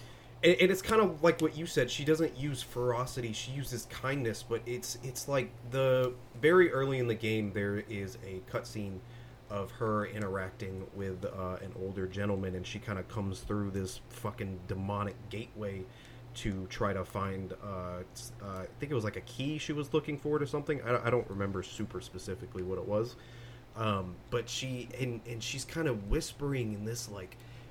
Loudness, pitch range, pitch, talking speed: -34 LUFS, 100-125 Hz, 115 Hz, 190 wpm